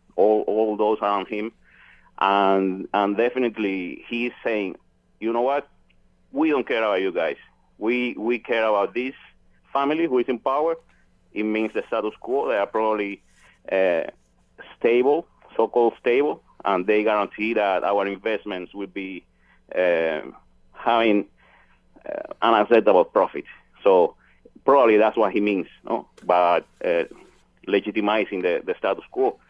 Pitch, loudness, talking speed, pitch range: 110 Hz, -22 LUFS, 140 wpm, 100-140 Hz